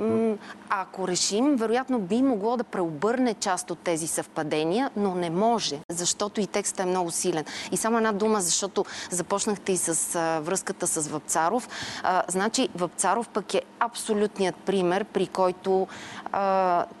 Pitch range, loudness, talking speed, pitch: 175-220 Hz, -26 LUFS, 150 wpm, 190 Hz